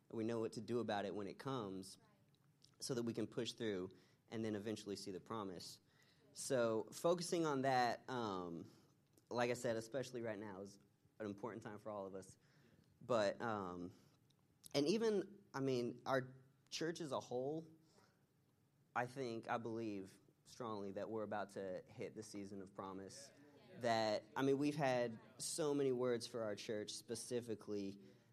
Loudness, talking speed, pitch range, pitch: -44 LUFS, 165 wpm, 105-140 Hz, 120 Hz